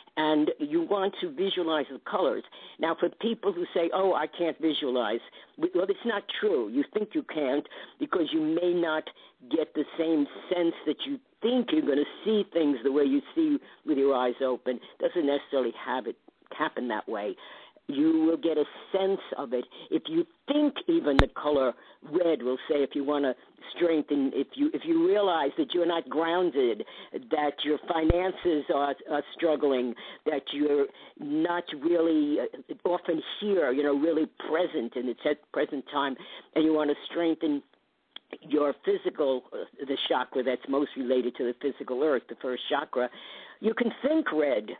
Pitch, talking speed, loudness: 165 Hz, 175 wpm, -28 LUFS